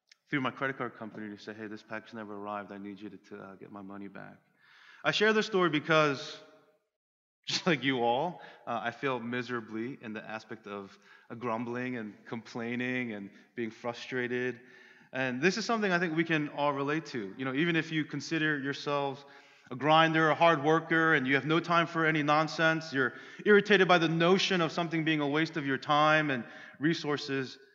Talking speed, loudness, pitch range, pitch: 200 wpm, -29 LUFS, 120-160 Hz, 140 Hz